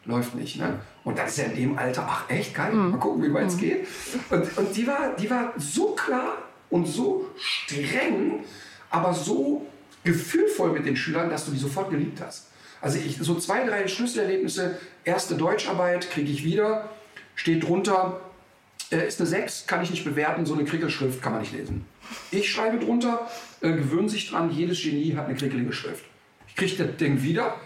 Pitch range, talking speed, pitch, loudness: 160-220 Hz, 190 wpm, 180 Hz, -26 LUFS